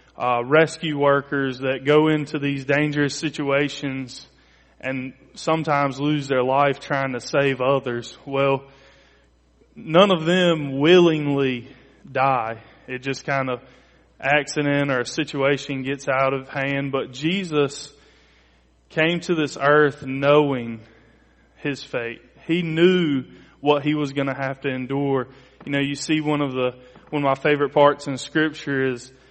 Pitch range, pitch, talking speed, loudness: 130-150 Hz, 140 Hz, 145 wpm, -21 LUFS